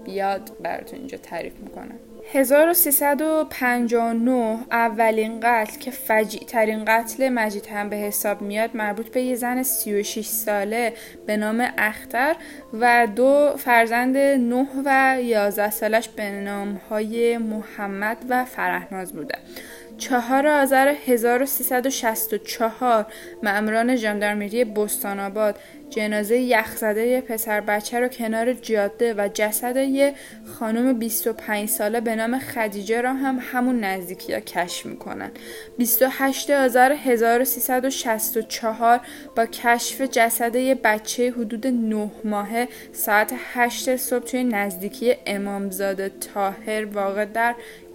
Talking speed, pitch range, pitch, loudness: 110 wpm, 215-255 Hz, 230 Hz, -22 LUFS